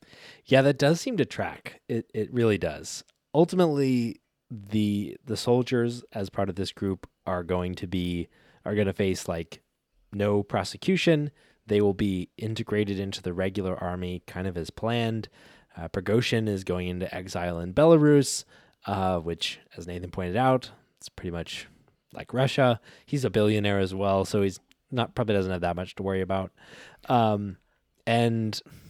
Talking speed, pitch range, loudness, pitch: 165 wpm, 95-120 Hz, -27 LUFS, 100 Hz